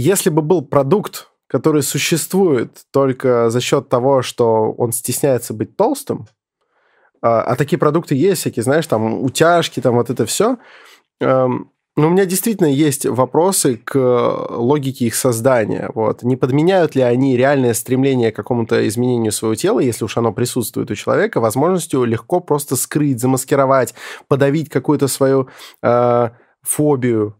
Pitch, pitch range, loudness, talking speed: 130 Hz, 120-150 Hz, -16 LUFS, 145 wpm